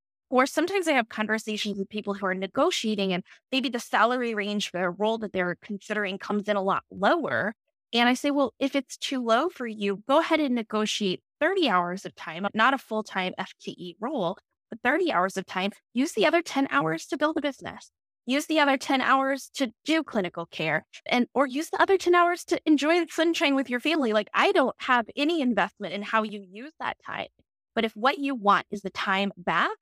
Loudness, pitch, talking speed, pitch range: -26 LUFS, 235 Hz, 215 wpm, 200-285 Hz